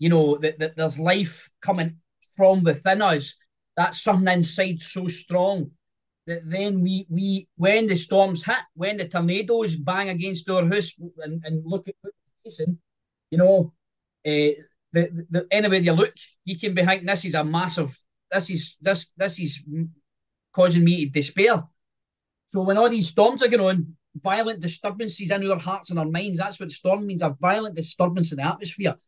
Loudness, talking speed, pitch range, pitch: -22 LUFS, 175 wpm, 160-195 Hz, 180 Hz